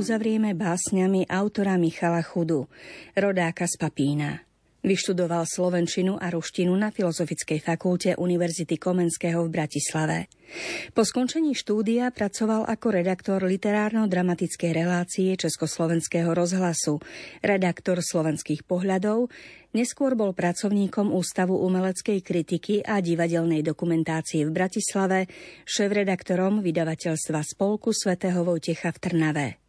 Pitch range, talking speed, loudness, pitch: 170-200 Hz, 100 wpm, -25 LUFS, 180 Hz